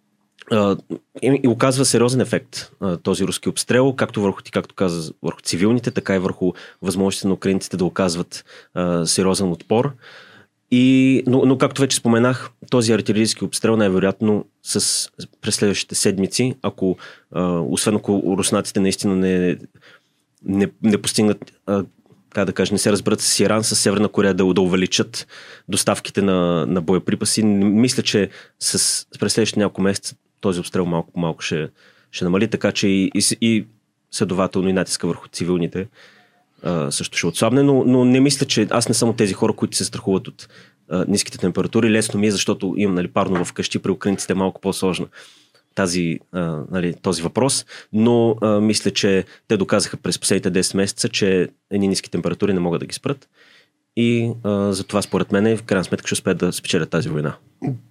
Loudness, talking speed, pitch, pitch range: -19 LUFS, 165 wpm, 100 Hz, 95-115 Hz